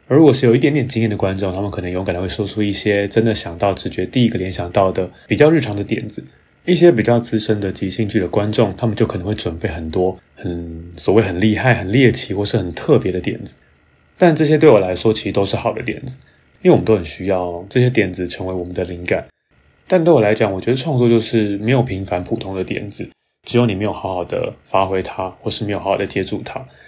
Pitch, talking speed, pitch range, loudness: 105 Hz, 360 characters per minute, 95-115 Hz, -17 LUFS